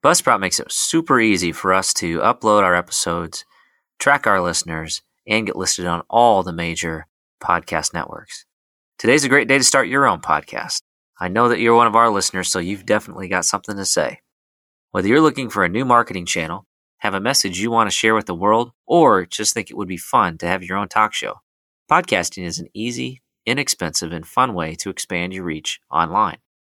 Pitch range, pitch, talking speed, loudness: 85-115 Hz, 95 Hz, 205 wpm, -18 LUFS